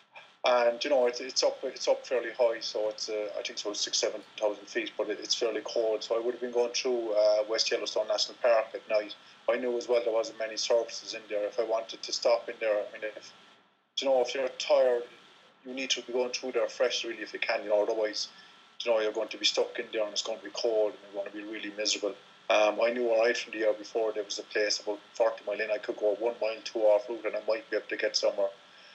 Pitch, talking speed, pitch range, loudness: 110 Hz, 280 wpm, 105-125 Hz, -30 LUFS